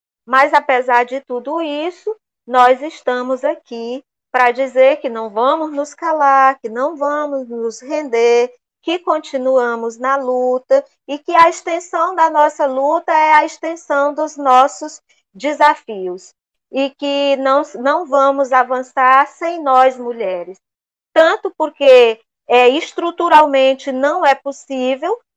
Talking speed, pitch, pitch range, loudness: 125 wpm, 275 Hz, 255-305 Hz, -15 LUFS